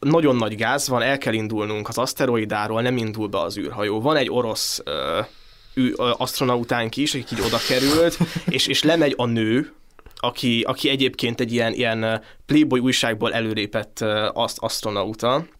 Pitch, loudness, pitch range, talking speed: 120 Hz, -21 LUFS, 110-135 Hz, 160 wpm